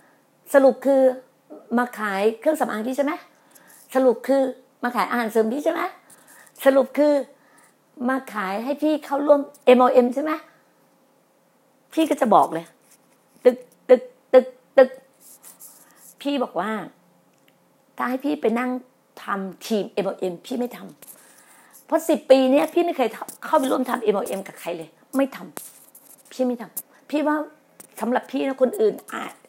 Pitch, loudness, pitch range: 260 Hz, -22 LUFS, 245-285 Hz